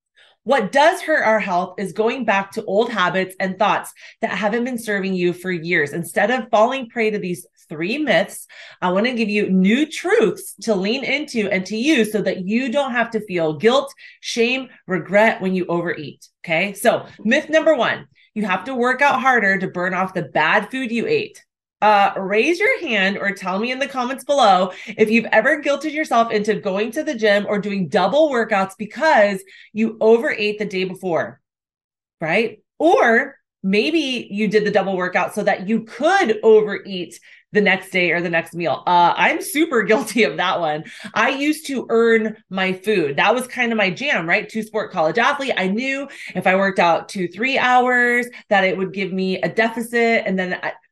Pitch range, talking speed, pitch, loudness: 190-250 Hz, 195 wpm, 215 Hz, -18 LUFS